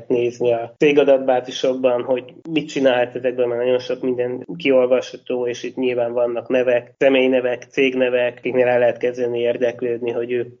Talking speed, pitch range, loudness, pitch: 145 wpm, 120-130 Hz, -19 LUFS, 125 Hz